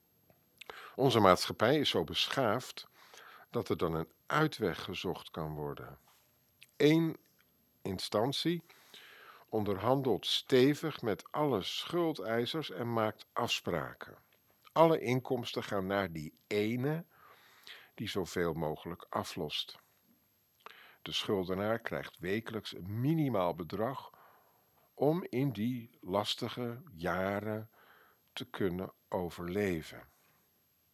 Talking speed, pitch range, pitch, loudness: 95 wpm, 95-145 Hz, 115 Hz, -34 LUFS